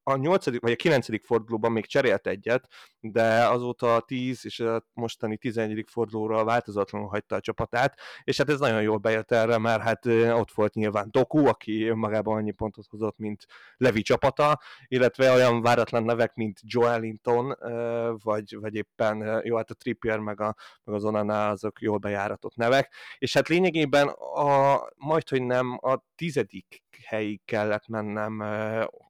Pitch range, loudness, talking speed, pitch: 110-125 Hz, -26 LUFS, 155 wpm, 115 Hz